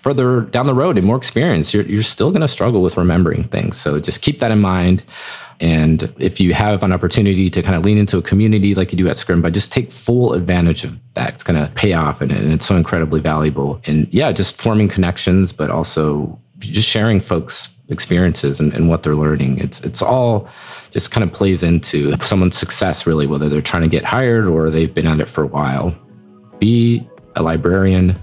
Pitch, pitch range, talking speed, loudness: 90 Hz, 80-105 Hz, 215 wpm, -15 LUFS